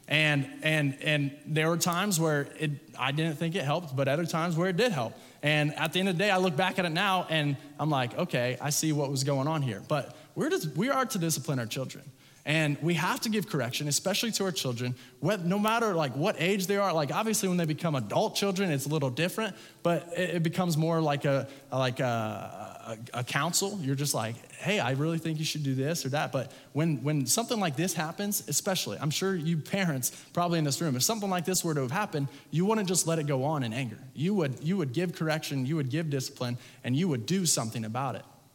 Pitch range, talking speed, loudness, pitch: 140-180 Hz, 240 wpm, -29 LUFS, 155 Hz